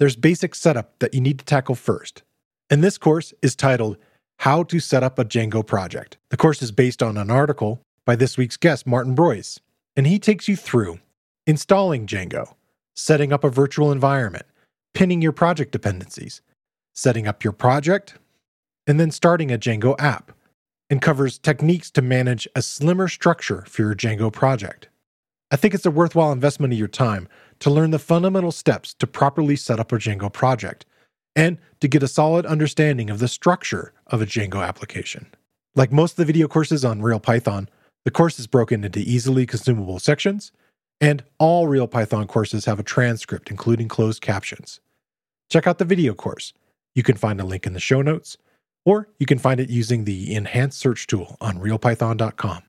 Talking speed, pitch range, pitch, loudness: 180 wpm, 115-155 Hz, 130 Hz, -20 LUFS